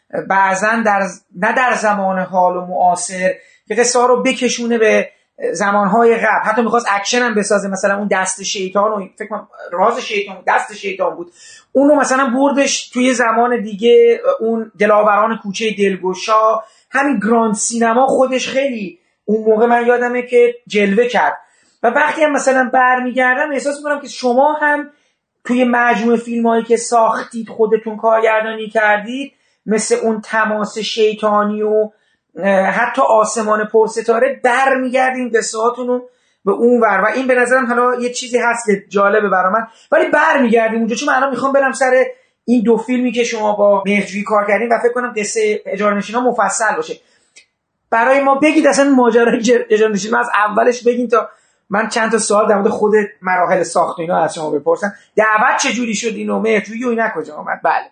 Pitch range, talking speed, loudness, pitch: 210-250 Hz, 170 wpm, -14 LUFS, 225 Hz